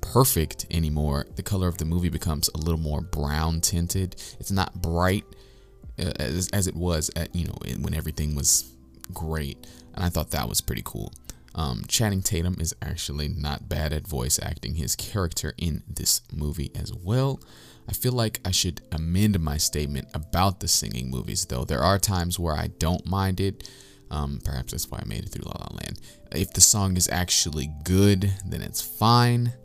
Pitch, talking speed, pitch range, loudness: 90 Hz, 185 wpm, 75-100 Hz, -25 LUFS